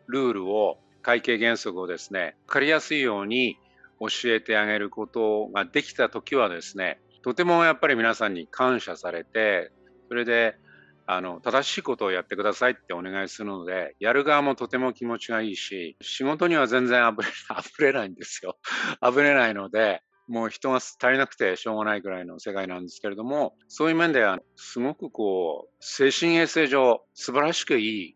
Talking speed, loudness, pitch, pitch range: 370 characters per minute, -25 LUFS, 115 Hz, 105-135 Hz